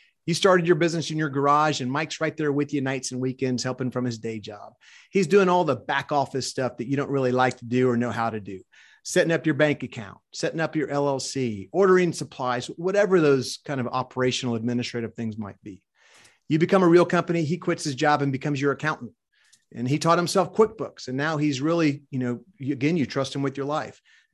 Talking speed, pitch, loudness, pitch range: 225 wpm, 140 Hz, -24 LUFS, 125-160 Hz